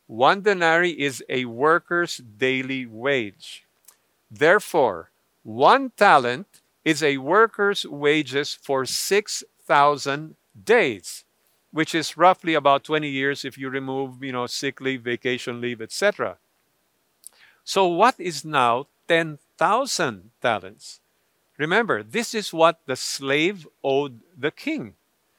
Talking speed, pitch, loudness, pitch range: 115 wpm, 145 Hz, -22 LUFS, 130-170 Hz